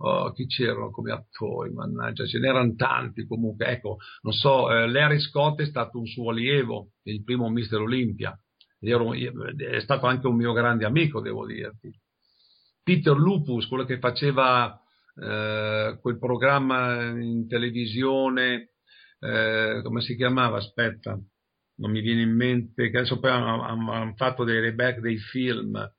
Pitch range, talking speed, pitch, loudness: 115-130 Hz, 150 wpm, 120 Hz, -25 LUFS